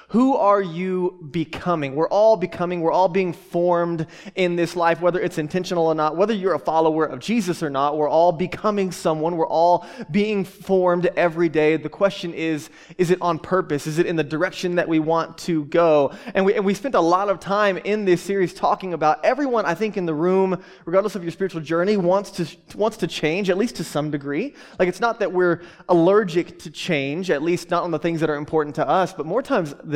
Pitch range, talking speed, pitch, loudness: 165-190 Hz, 225 wpm, 175 Hz, -21 LUFS